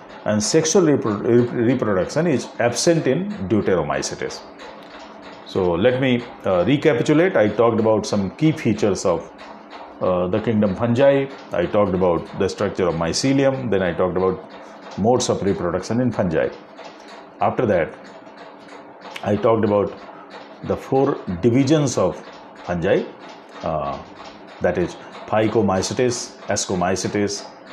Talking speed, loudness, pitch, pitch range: 115 wpm, -20 LUFS, 120 Hz, 105-135 Hz